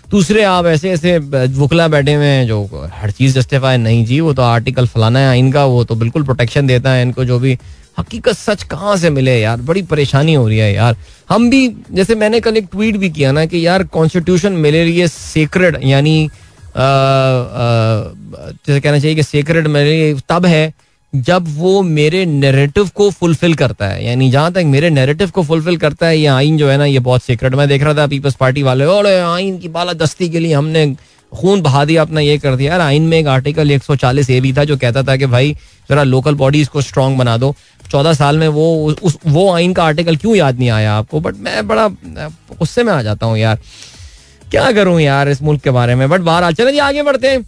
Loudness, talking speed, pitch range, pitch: -12 LUFS, 215 wpm, 130-170 Hz, 145 Hz